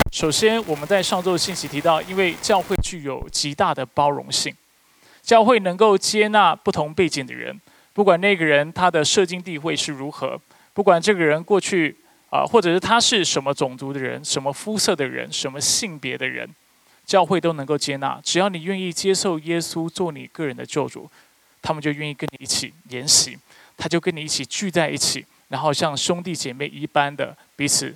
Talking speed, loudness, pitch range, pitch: 295 characters per minute, -20 LUFS, 145-190 Hz, 165 Hz